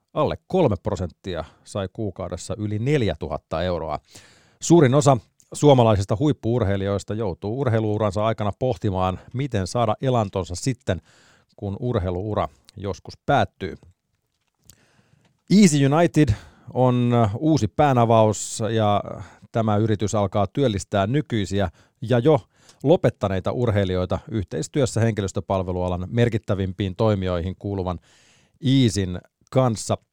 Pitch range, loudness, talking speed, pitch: 100-125 Hz, -22 LUFS, 90 wpm, 110 Hz